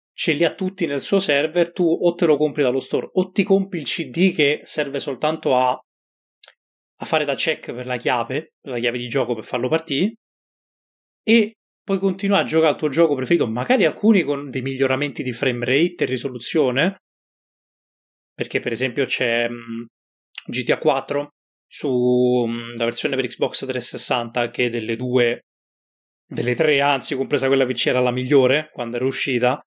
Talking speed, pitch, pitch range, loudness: 175 wpm, 135 Hz, 125-160 Hz, -20 LUFS